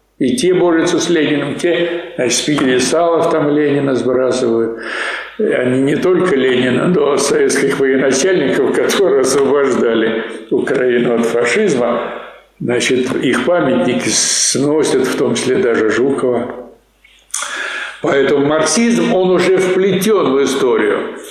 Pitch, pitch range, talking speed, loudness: 150 Hz, 130-185 Hz, 120 wpm, -14 LUFS